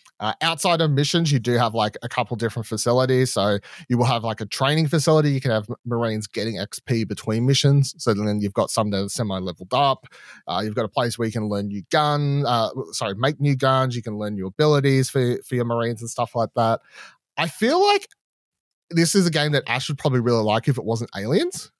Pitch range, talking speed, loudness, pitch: 110-145 Hz, 230 wpm, -22 LUFS, 120 Hz